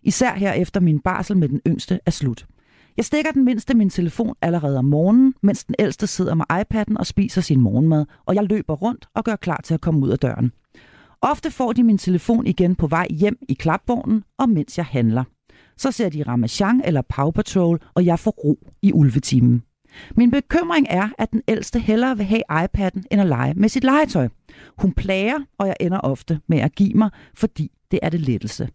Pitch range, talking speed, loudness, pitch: 155-220 Hz, 210 wpm, -20 LUFS, 190 Hz